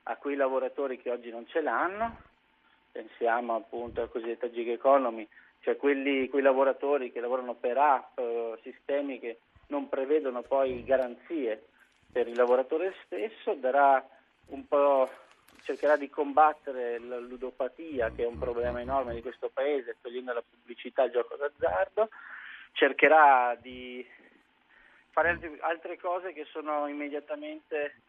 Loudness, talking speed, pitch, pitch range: -29 LUFS, 135 wpm, 135 Hz, 120-155 Hz